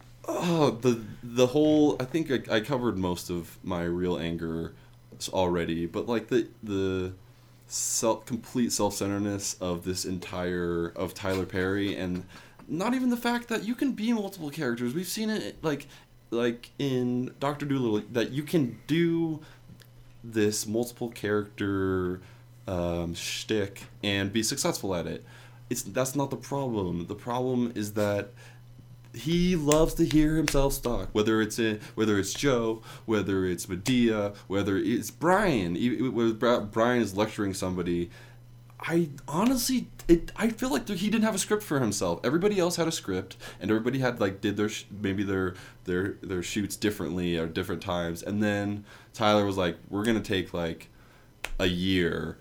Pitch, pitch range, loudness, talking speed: 115 Hz, 95-130 Hz, -28 LUFS, 160 wpm